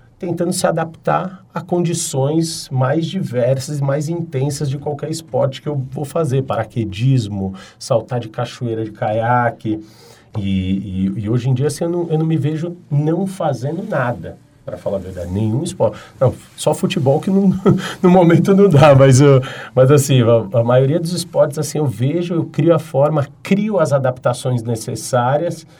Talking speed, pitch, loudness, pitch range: 170 wpm, 145 Hz, -17 LUFS, 125-170 Hz